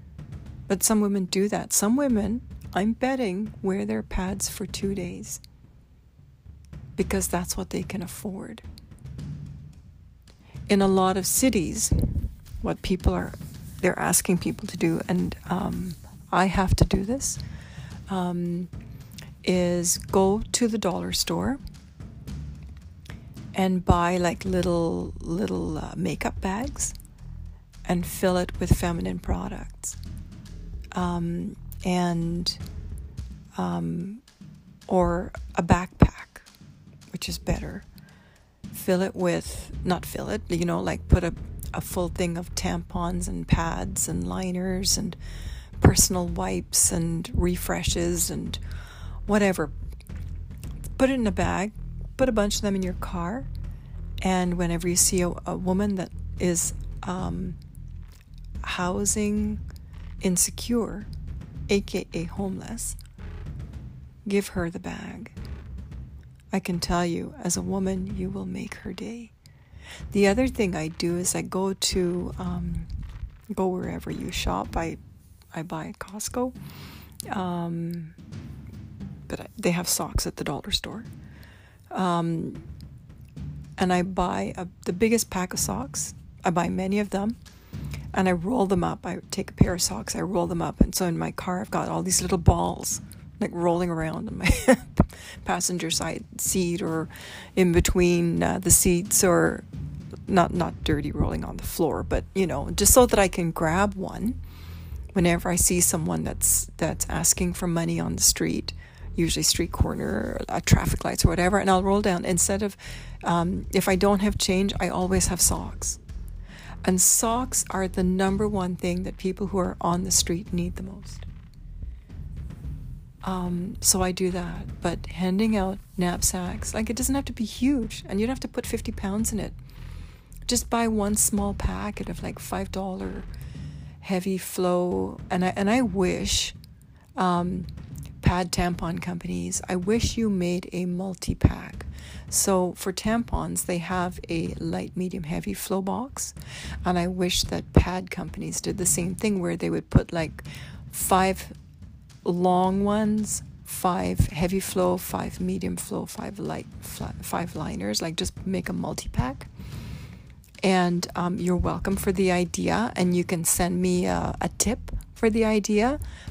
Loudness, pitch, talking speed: -25 LUFS, 180 Hz, 150 wpm